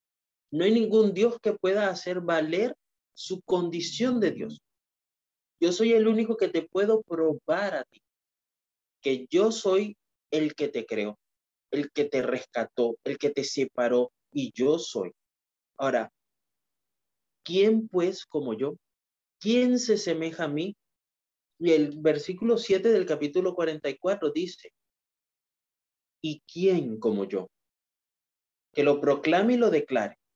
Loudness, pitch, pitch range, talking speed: -27 LUFS, 165 Hz, 140-205 Hz, 135 wpm